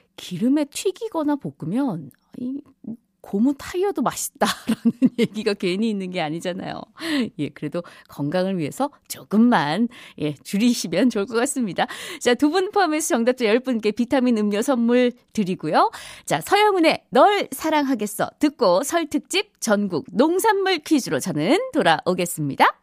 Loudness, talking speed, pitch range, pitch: -21 LUFS, 305 characters per minute, 200-295 Hz, 240 Hz